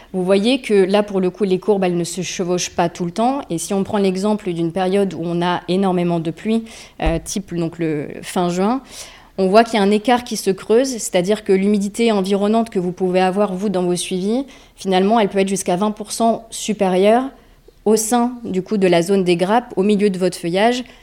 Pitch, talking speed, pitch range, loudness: 195 Hz, 225 wpm, 180-215 Hz, -18 LUFS